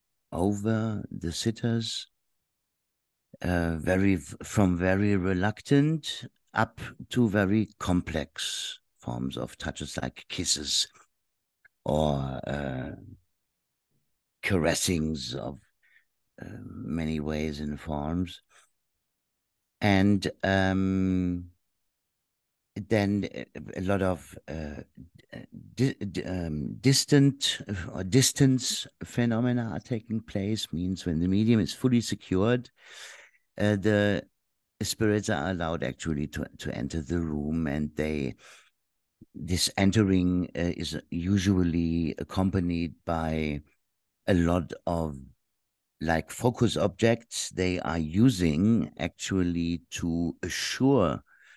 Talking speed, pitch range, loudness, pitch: 95 wpm, 80-105 Hz, -28 LUFS, 90 Hz